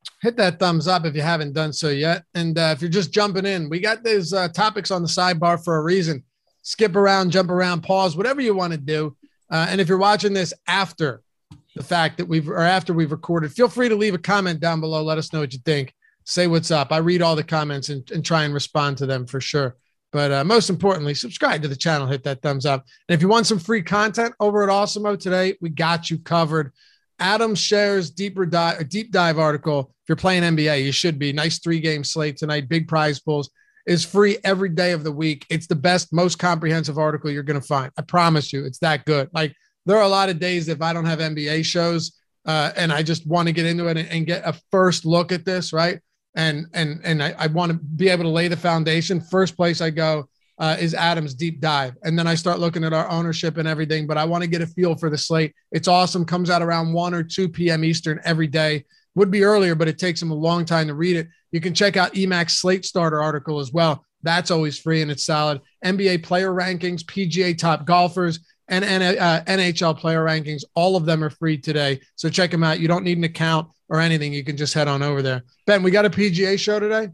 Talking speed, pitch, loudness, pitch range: 245 wpm, 165 Hz, -20 LUFS, 155-185 Hz